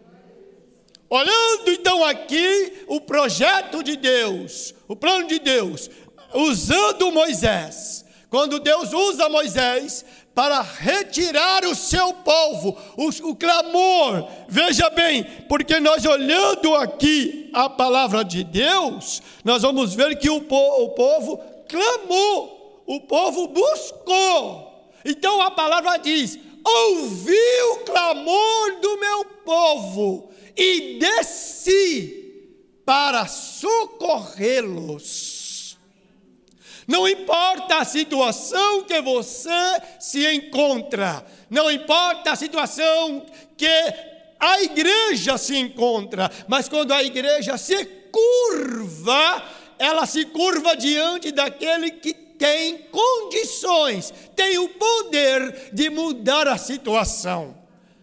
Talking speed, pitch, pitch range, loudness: 100 wpm, 315 Hz, 265-360 Hz, -19 LUFS